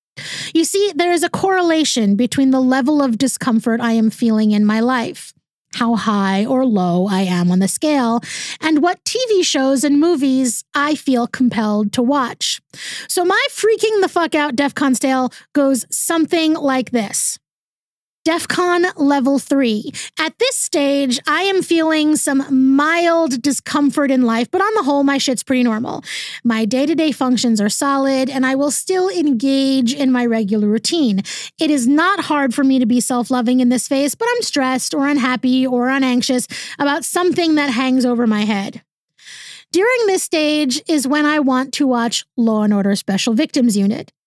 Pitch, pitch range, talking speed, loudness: 270 Hz, 240-310 Hz, 170 wpm, -16 LUFS